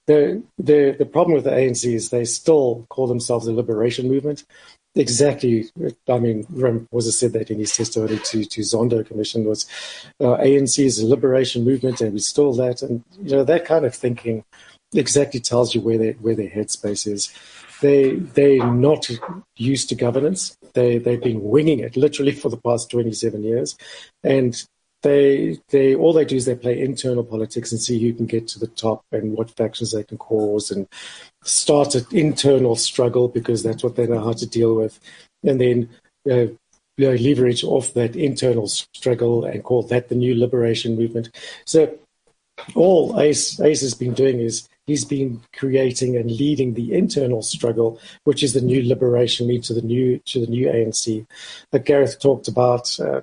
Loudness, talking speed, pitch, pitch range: -19 LUFS, 185 wpm, 120 Hz, 115-135 Hz